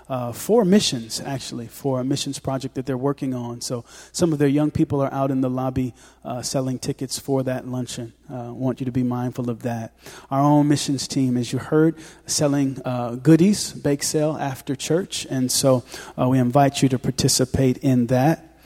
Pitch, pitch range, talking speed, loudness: 135 Hz, 125-145 Hz, 195 wpm, -22 LUFS